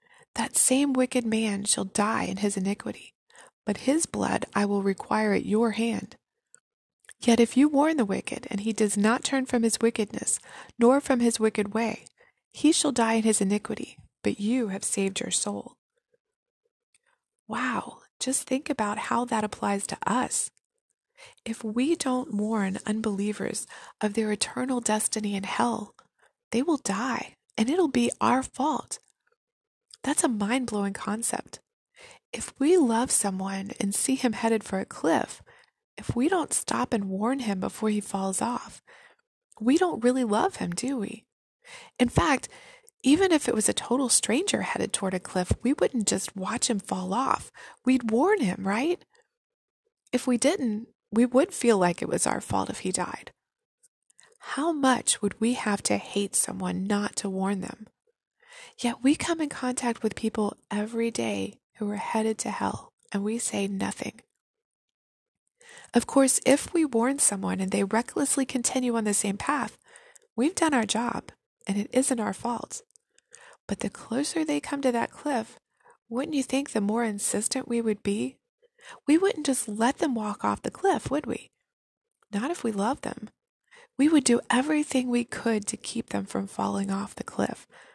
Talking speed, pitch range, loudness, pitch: 170 wpm, 210-290 Hz, -27 LUFS, 240 Hz